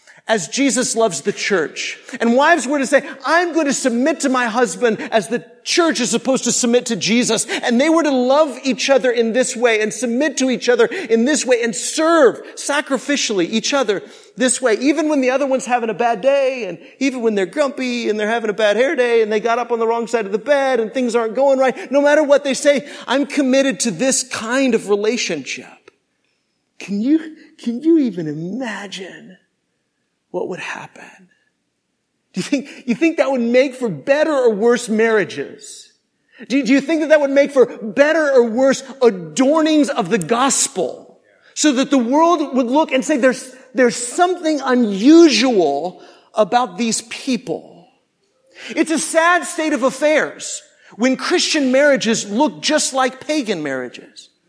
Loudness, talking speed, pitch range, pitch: -16 LUFS, 185 wpm, 235-290 Hz, 260 Hz